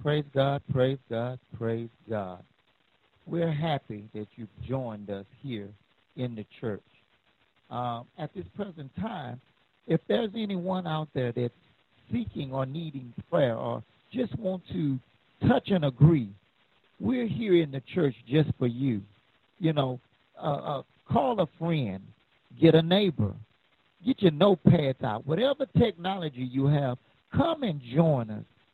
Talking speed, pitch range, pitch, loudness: 140 wpm, 120-170 Hz, 140 Hz, -29 LUFS